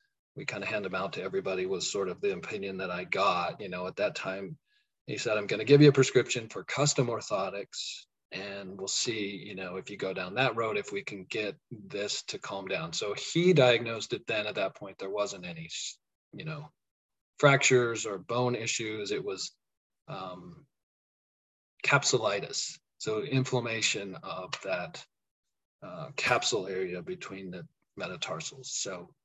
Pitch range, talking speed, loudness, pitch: 110-165 Hz, 170 wpm, -30 LUFS, 130 Hz